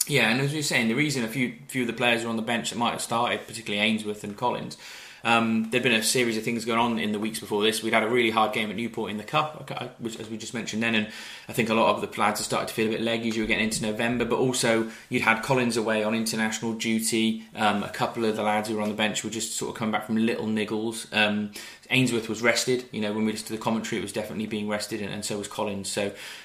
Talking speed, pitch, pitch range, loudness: 295 wpm, 110 Hz, 110-115 Hz, -26 LUFS